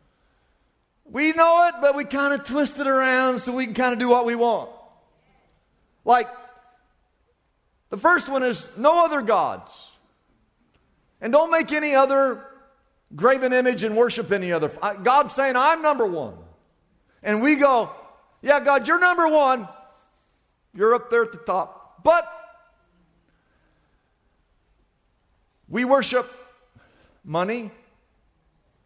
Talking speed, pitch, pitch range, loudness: 125 wpm, 265 Hz, 245-295 Hz, -21 LUFS